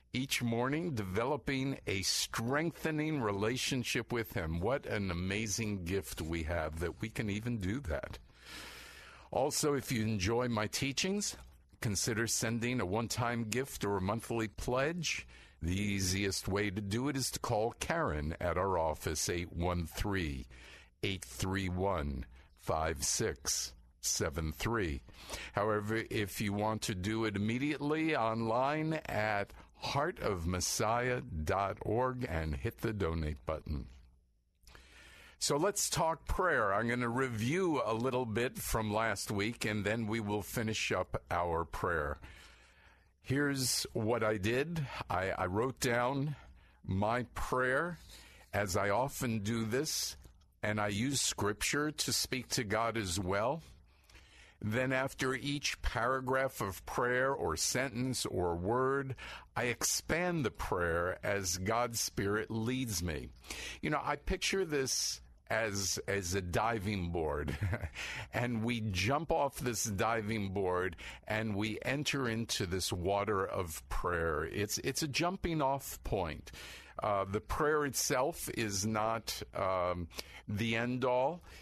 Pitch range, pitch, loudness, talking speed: 95-125 Hz, 110 Hz, -35 LUFS, 130 wpm